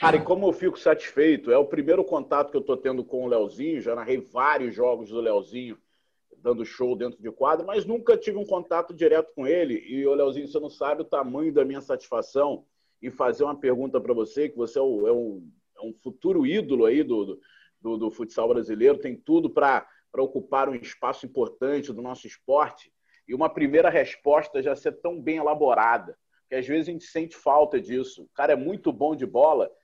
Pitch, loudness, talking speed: 160 Hz, -25 LUFS, 210 wpm